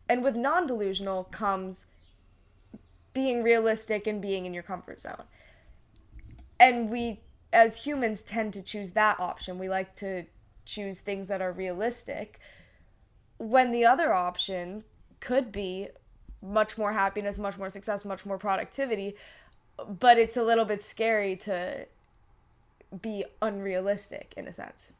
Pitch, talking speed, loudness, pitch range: 205 Hz, 135 wpm, -28 LUFS, 190-225 Hz